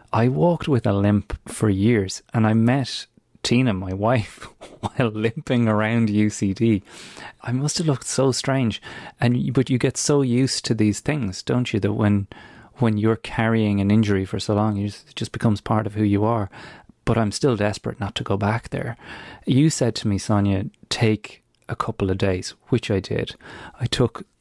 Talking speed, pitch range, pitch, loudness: 185 wpm, 105-125 Hz, 110 Hz, -22 LUFS